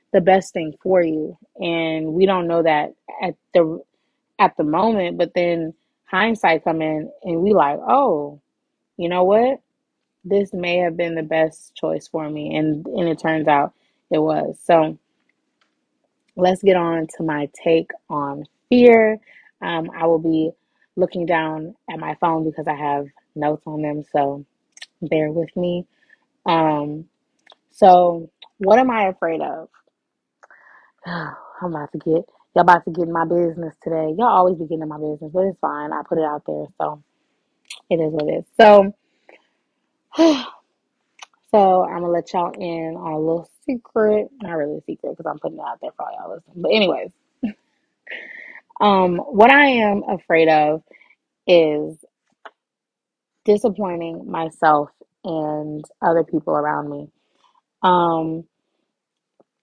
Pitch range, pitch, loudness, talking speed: 160-205 Hz, 170 Hz, -19 LUFS, 155 wpm